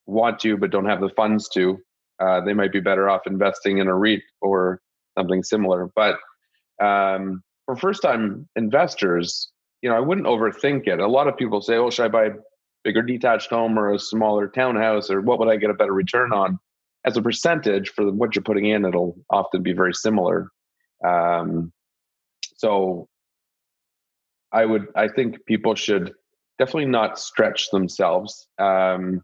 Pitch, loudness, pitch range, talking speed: 100 Hz, -21 LUFS, 95-110 Hz, 175 wpm